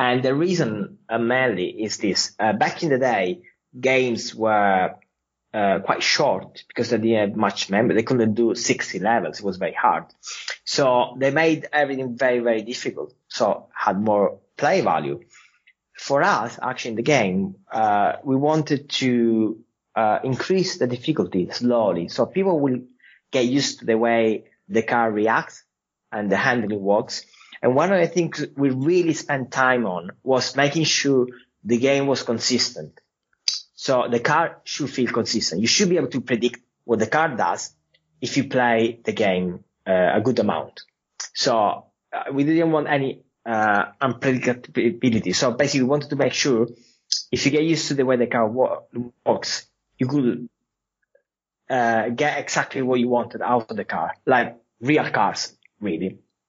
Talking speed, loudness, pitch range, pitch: 165 wpm, -22 LUFS, 115-140 Hz, 125 Hz